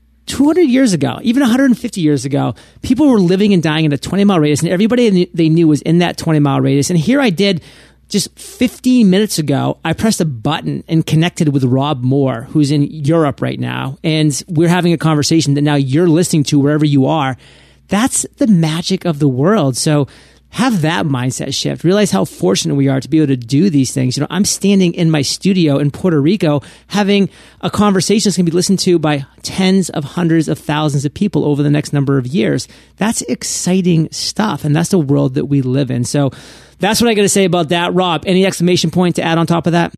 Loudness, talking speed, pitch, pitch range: -14 LUFS, 220 wpm, 165 Hz, 145-190 Hz